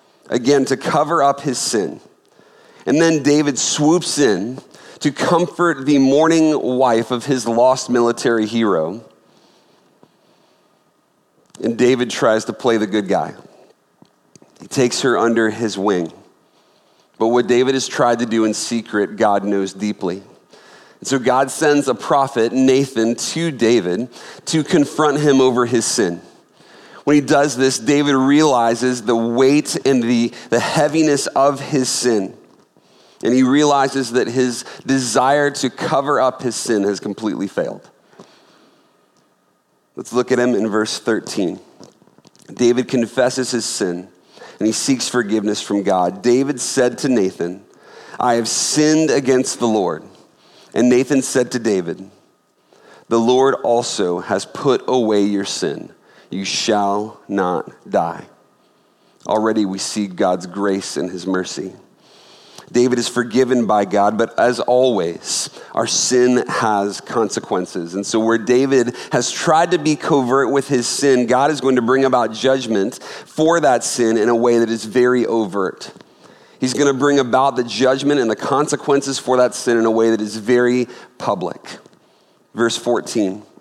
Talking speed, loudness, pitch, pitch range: 150 wpm, -17 LUFS, 125 Hz, 115-135 Hz